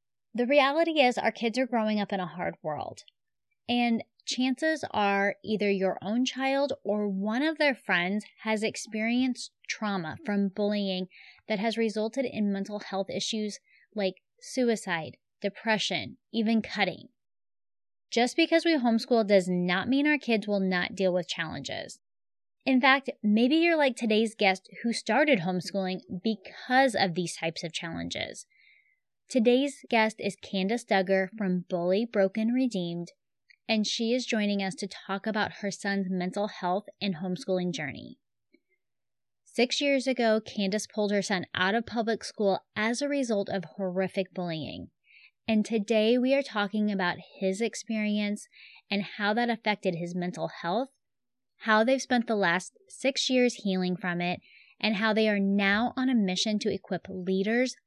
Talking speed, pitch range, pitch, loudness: 155 wpm, 190-240 Hz, 210 Hz, -28 LUFS